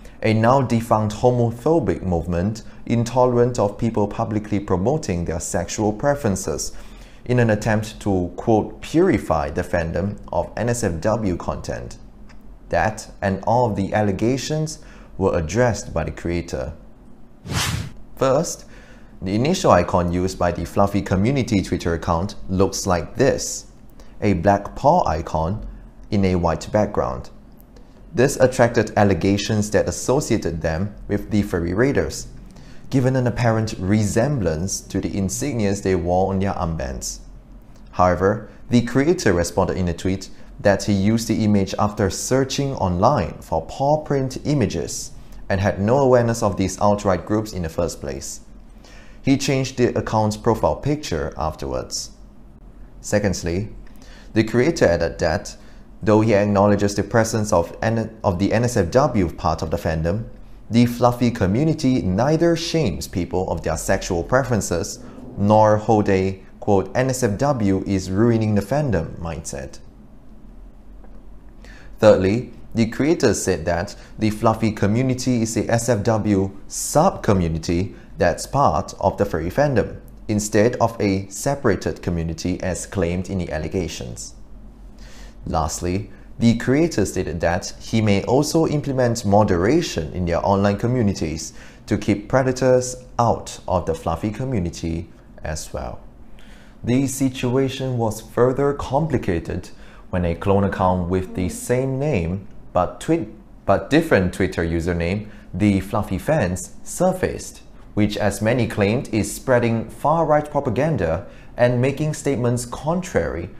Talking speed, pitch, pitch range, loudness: 130 wpm, 105 Hz, 95-120 Hz, -21 LUFS